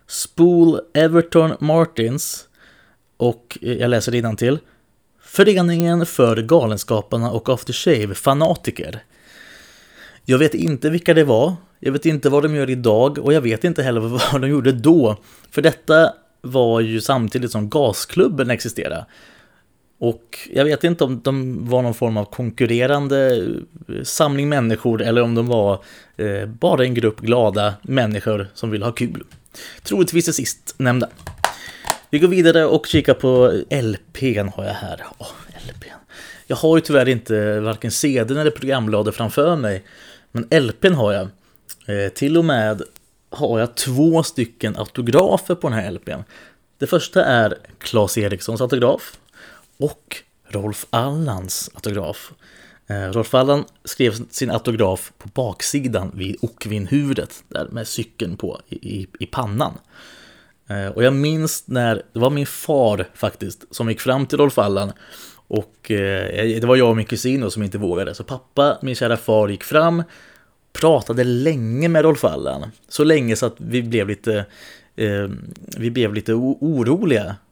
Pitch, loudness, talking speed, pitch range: 125 Hz, -18 LUFS, 145 wpm, 110-145 Hz